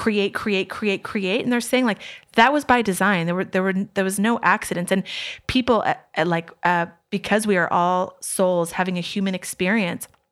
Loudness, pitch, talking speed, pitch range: -21 LUFS, 195 Hz, 200 wpm, 180-220 Hz